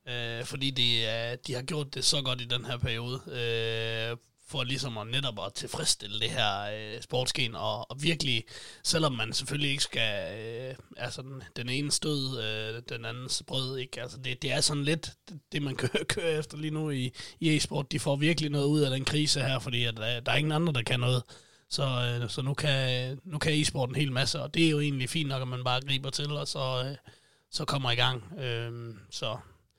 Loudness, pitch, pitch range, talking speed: -30 LUFS, 130 Hz, 120-145 Hz, 220 wpm